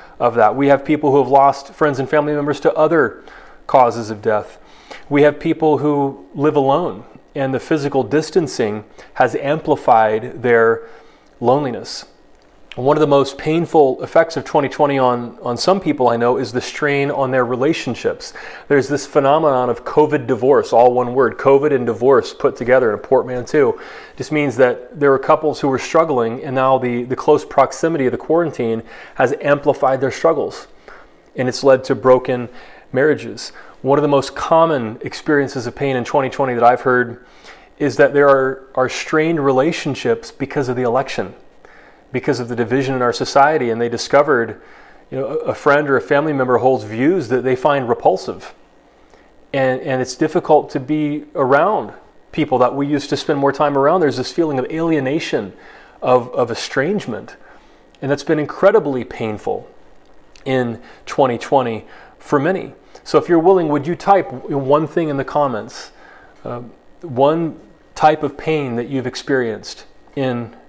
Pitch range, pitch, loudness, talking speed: 125-150 Hz, 140 Hz, -16 LUFS, 170 wpm